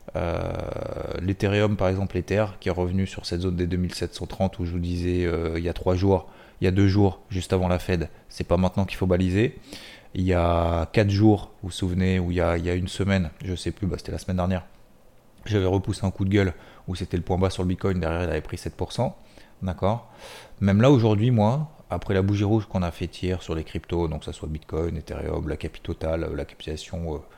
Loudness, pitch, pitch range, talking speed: -25 LUFS, 90 Hz, 85-100 Hz, 240 wpm